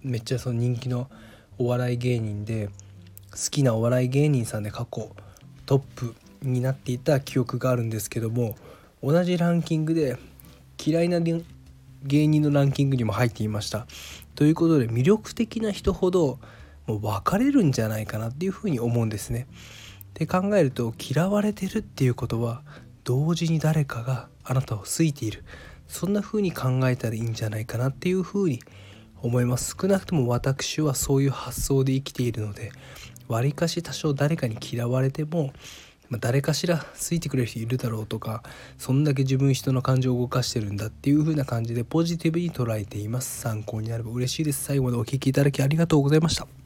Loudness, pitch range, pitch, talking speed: -25 LUFS, 115-150 Hz, 130 Hz, 395 characters per minute